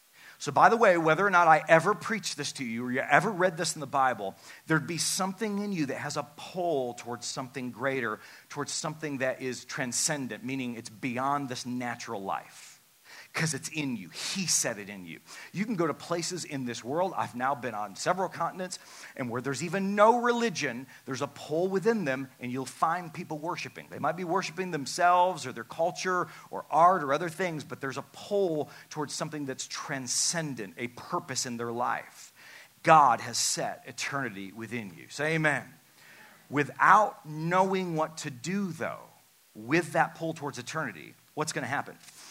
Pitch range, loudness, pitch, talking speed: 130-175 Hz, -29 LUFS, 145 Hz, 185 wpm